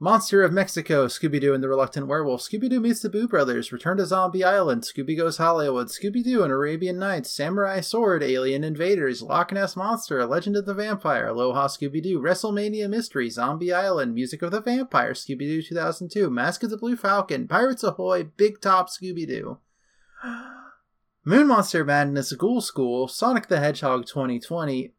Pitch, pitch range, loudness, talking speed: 180 Hz, 145-205 Hz, -23 LUFS, 175 wpm